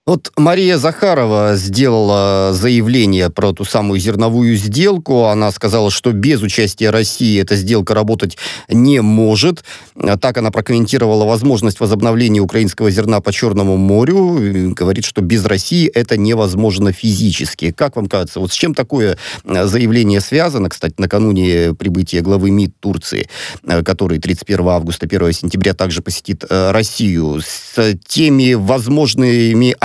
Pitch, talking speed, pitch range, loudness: 105 Hz, 130 wpm, 95-115 Hz, -13 LUFS